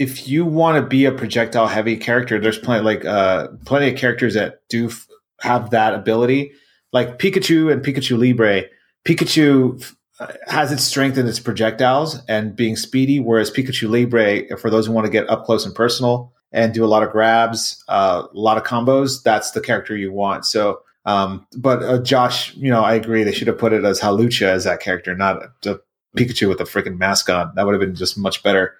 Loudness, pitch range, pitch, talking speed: -17 LUFS, 110-130 Hz, 115 Hz, 210 wpm